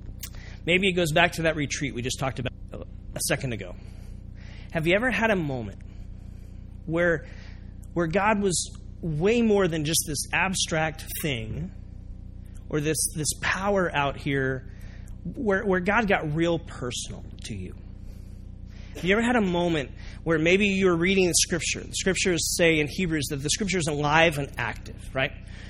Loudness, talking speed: -25 LUFS, 165 wpm